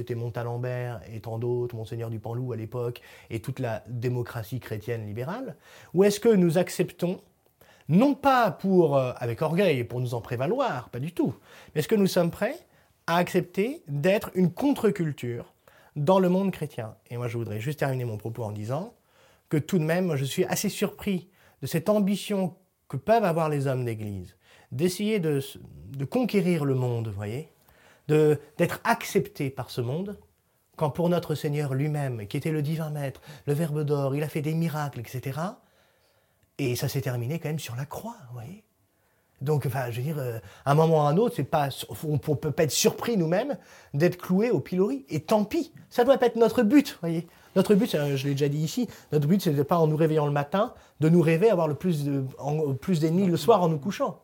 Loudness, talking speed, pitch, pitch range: -26 LUFS, 210 wpm, 150 Hz, 125-180 Hz